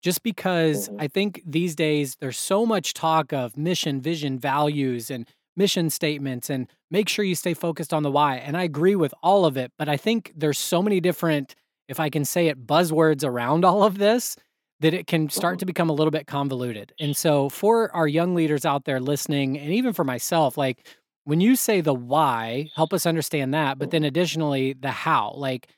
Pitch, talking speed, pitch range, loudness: 155 Hz, 205 wpm, 140-175 Hz, -23 LUFS